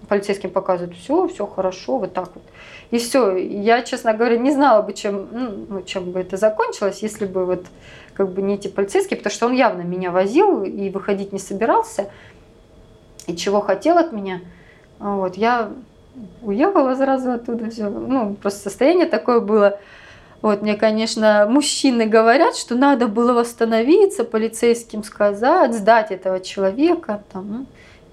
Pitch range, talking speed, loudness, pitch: 195-245 Hz, 150 wpm, -19 LUFS, 215 Hz